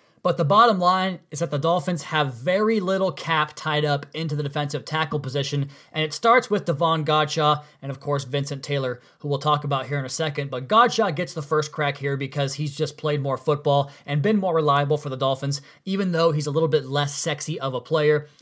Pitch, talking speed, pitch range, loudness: 150 Hz, 225 wpm, 140-165 Hz, -23 LUFS